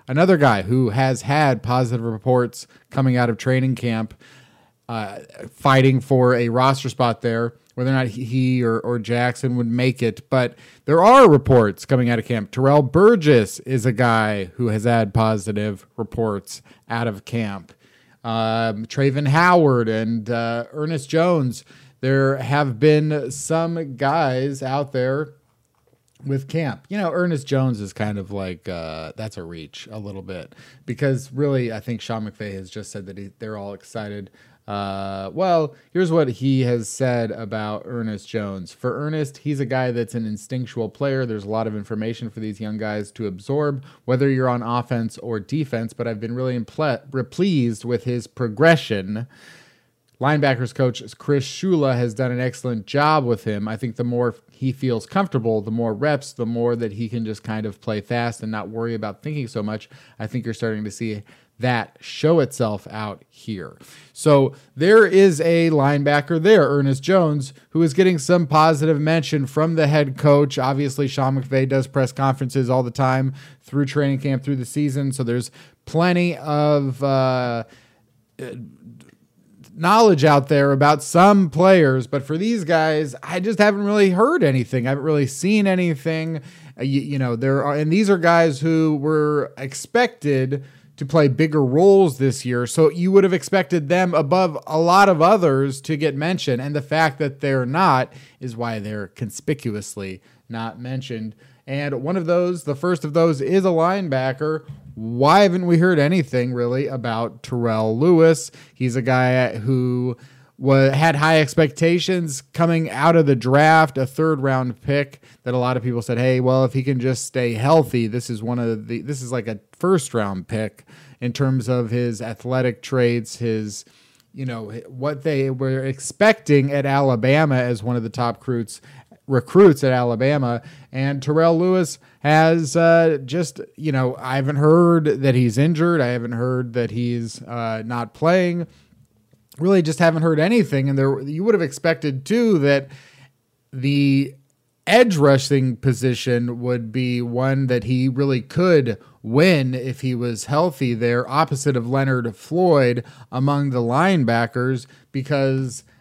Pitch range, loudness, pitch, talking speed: 120-150 Hz, -19 LUFS, 130 Hz, 170 wpm